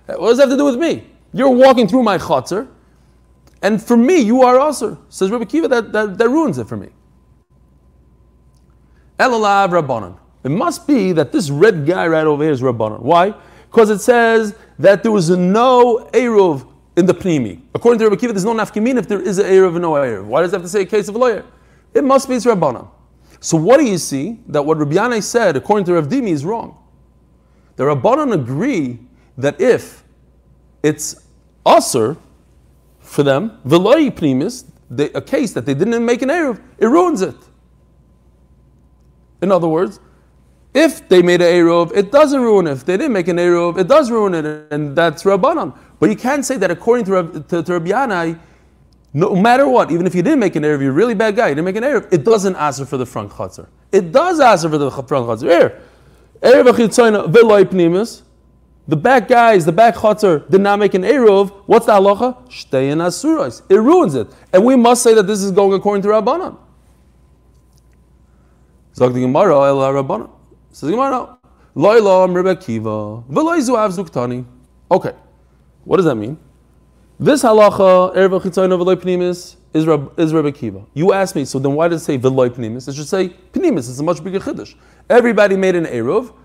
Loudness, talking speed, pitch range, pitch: -14 LUFS, 185 wpm, 130-220 Hz, 180 Hz